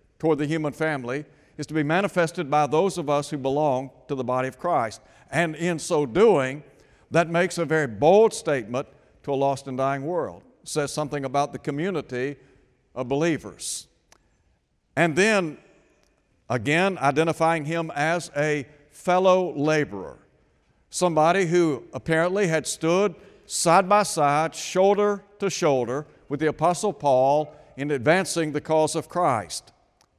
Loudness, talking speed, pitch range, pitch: -24 LUFS, 145 wpm, 140-170 Hz, 150 Hz